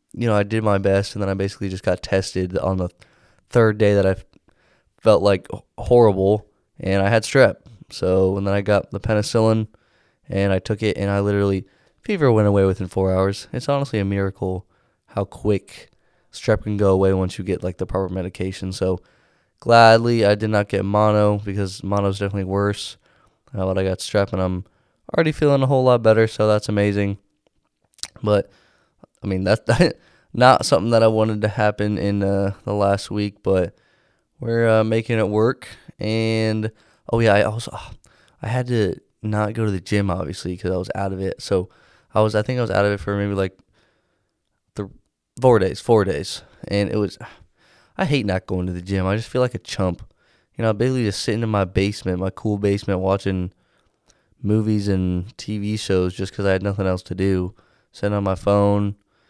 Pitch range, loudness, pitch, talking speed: 95-110 Hz, -20 LUFS, 100 Hz, 200 wpm